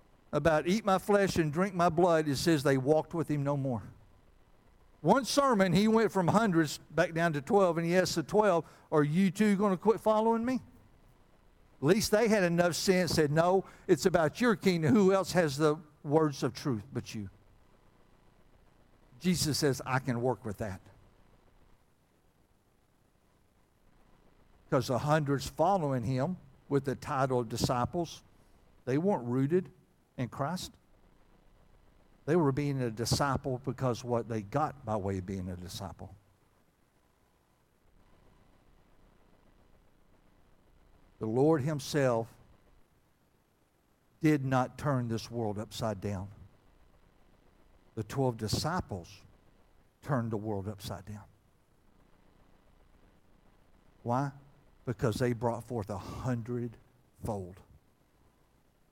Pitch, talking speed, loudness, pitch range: 130 Hz, 125 wpm, -30 LUFS, 110-165 Hz